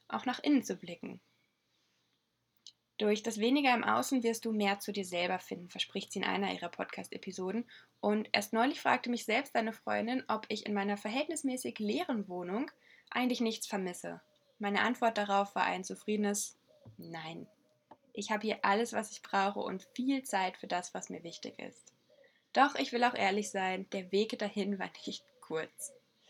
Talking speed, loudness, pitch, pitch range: 175 wpm, -34 LUFS, 215 Hz, 200-245 Hz